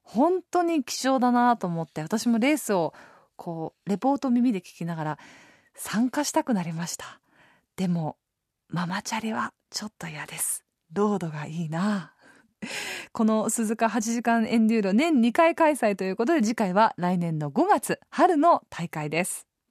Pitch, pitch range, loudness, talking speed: 220 Hz, 175-245 Hz, -25 LUFS, 295 characters per minute